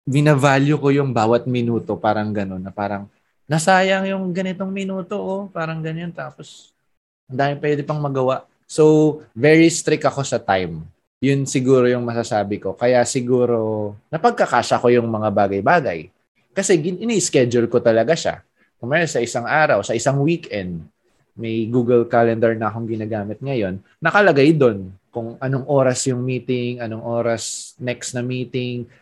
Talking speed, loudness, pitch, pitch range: 145 wpm, -19 LUFS, 125 Hz, 115-150 Hz